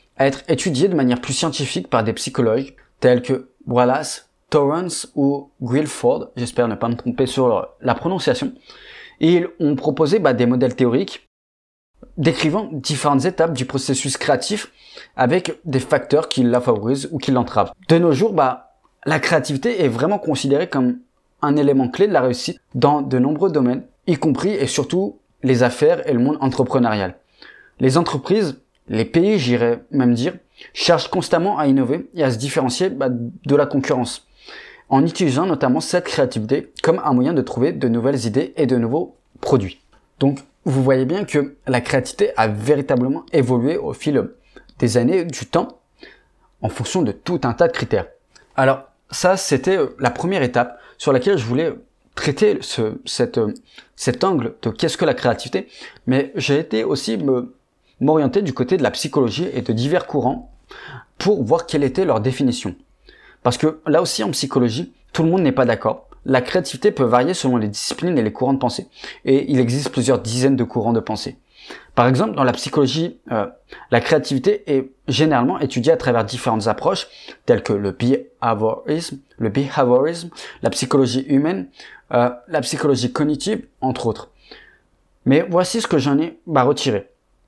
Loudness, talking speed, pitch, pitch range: -19 LUFS, 170 wpm, 135 Hz, 125-155 Hz